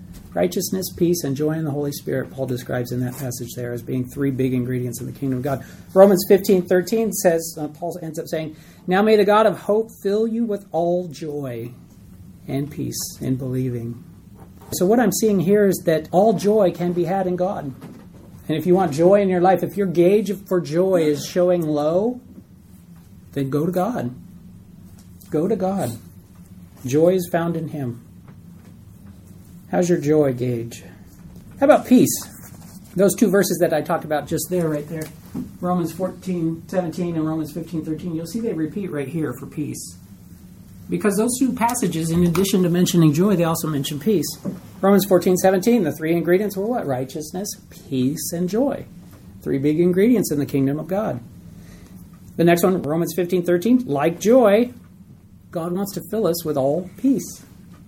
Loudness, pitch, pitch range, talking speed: -20 LUFS, 165 Hz, 135-190 Hz, 175 wpm